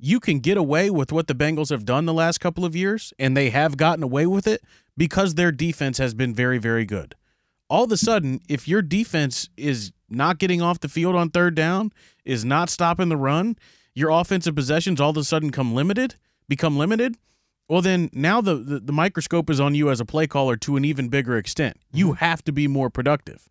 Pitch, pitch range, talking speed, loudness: 155 Hz, 140-175 Hz, 220 wpm, -22 LUFS